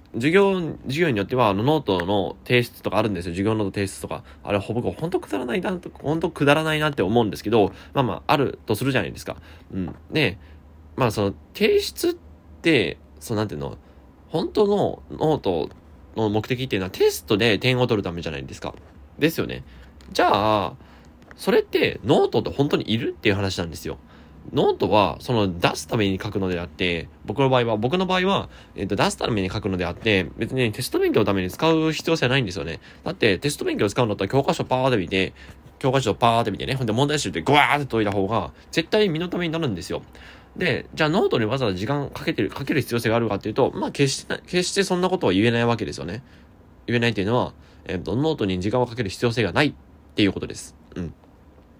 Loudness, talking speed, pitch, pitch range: -23 LUFS, 455 characters per minute, 110 Hz, 95-140 Hz